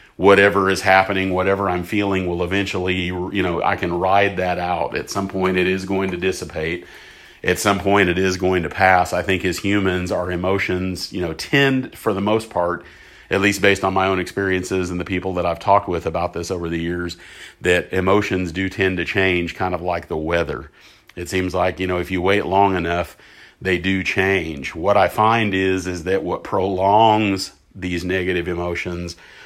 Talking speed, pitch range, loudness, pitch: 200 wpm, 90-95 Hz, -19 LUFS, 95 Hz